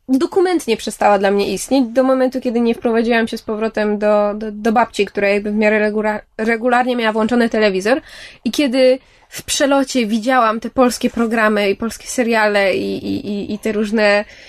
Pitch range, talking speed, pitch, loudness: 210-245 Hz, 180 wpm, 225 Hz, -16 LUFS